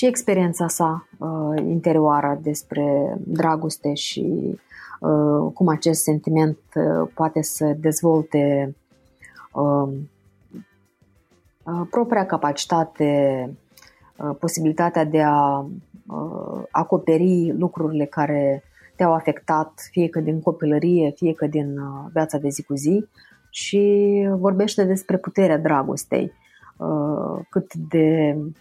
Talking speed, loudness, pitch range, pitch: 105 wpm, -21 LUFS, 145-170 Hz, 155 Hz